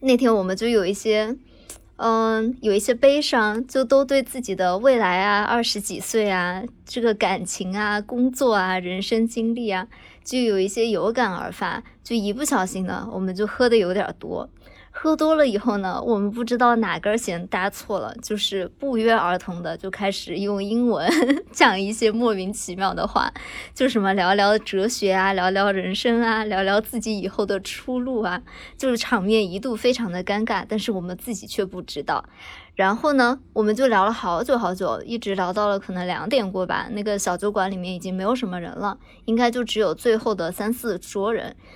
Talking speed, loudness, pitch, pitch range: 280 characters per minute, -22 LUFS, 215 Hz, 190-235 Hz